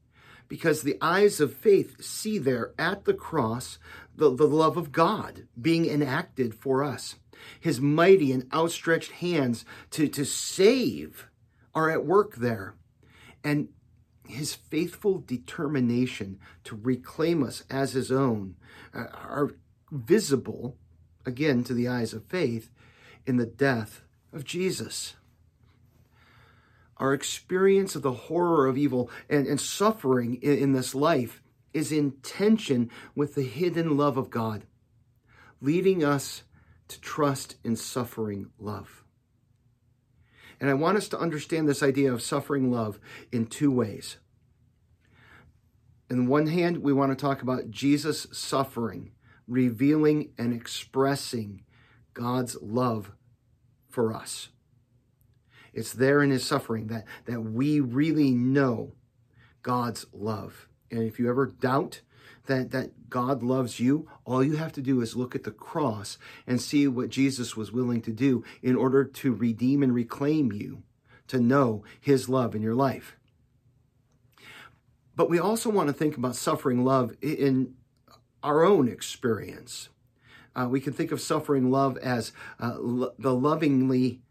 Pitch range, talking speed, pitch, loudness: 120-140 Hz, 140 wpm, 125 Hz, -27 LUFS